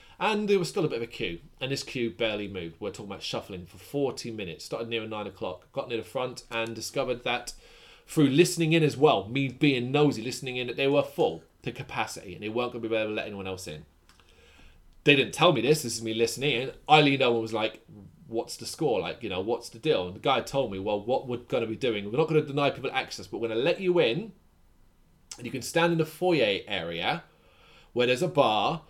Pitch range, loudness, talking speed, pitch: 105-145 Hz, -28 LUFS, 255 wpm, 125 Hz